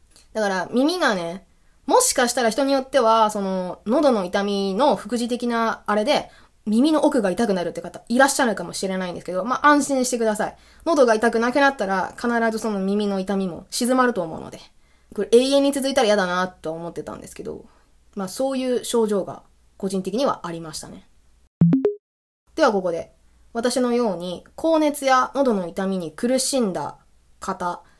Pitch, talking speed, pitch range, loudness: 225 Hz, 345 characters per minute, 190-260 Hz, -21 LUFS